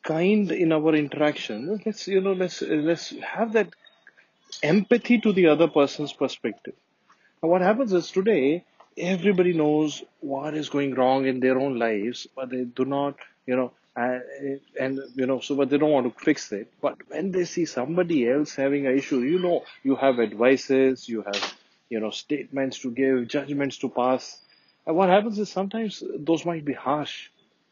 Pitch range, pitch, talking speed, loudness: 130-175 Hz, 145 Hz, 180 wpm, -24 LUFS